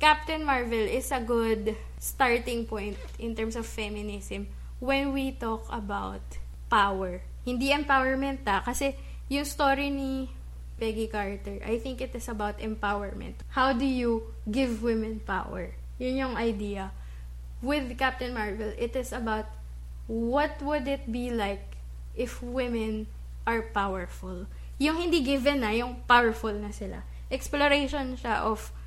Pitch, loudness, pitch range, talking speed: 230 Hz, -29 LUFS, 200-265 Hz, 135 wpm